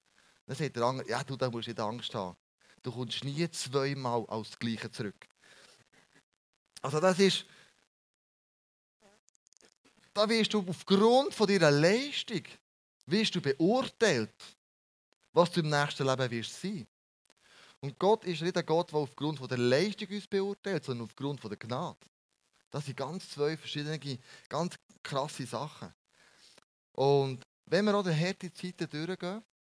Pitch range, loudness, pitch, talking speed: 130-185 Hz, -32 LUFS, 150 Hz, 145 wpm